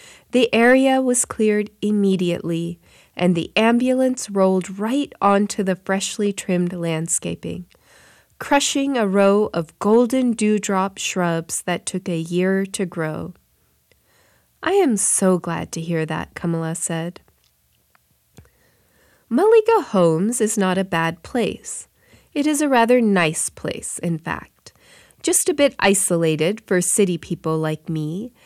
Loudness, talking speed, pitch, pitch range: -19 LUFS, 130 wpm, 195 Hz, 170-230 Hz